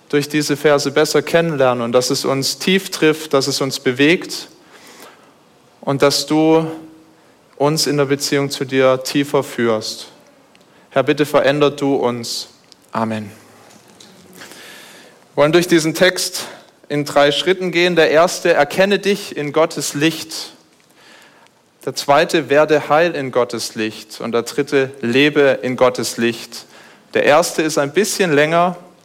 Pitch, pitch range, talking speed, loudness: 145 Hz, 130-160 Hz, 140 wpm, -16 LUFS